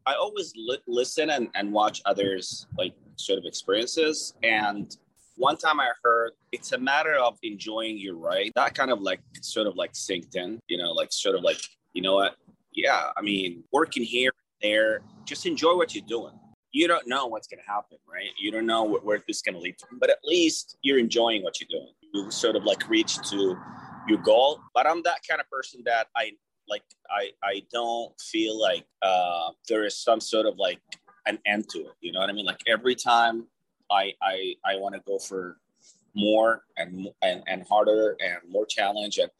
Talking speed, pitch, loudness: 210 wpm, 115 Hz, -26 LUFS